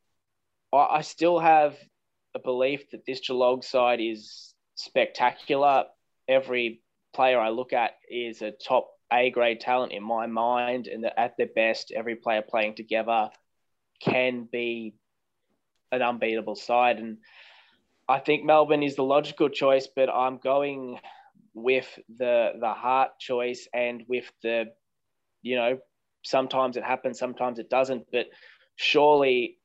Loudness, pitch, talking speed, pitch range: -26 LUFS, 125 Hz, 140 wpm, 115-130 Hz